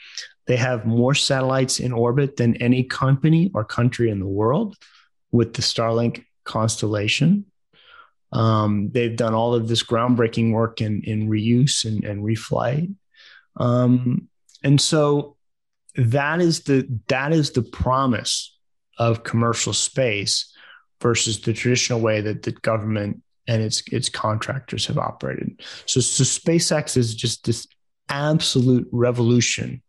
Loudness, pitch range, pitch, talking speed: -21 LUFS, 115-135 Hz, 120 Hz, 135 wpm